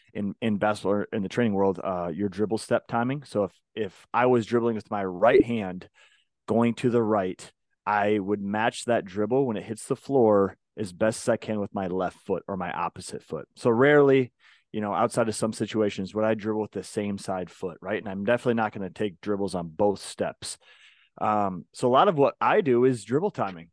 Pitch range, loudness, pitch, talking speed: 100-120 Hz, -26 LUFS, 110 Hz, 225 wpm